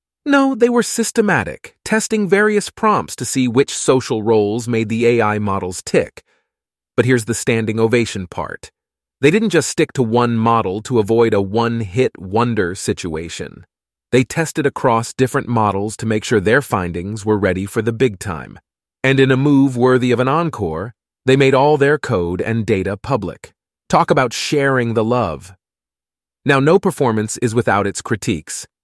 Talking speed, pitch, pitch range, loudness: 170 wpm, 115 Hz, 105-135 Hz, -16 LUFS